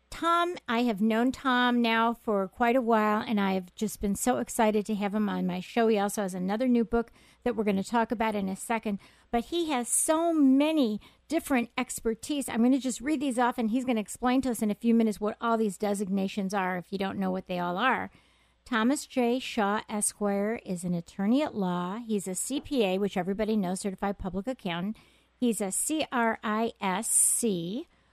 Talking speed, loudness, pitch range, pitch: 205 wpm, -28 LUFS, 200-245 Hz, 220 Hz